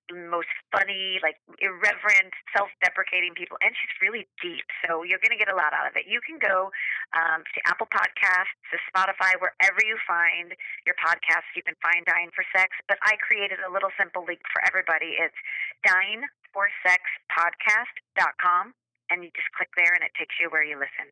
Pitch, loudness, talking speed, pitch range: 185 Hz, -24 LUFS, 185 wpm, 180-200 Hz